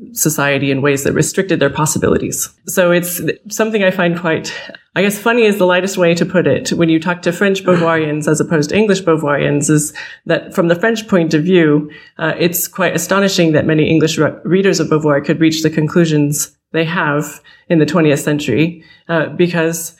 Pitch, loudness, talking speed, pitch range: 165 Hz, -14 LUFS, 195 wpm, 155-180 Hz